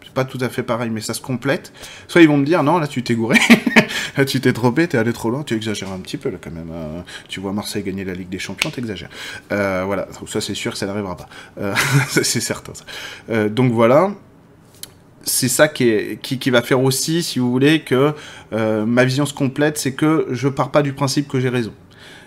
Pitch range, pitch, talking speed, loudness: 105-140 Hz, 125 Hz, 245 wpm, -18 LUFS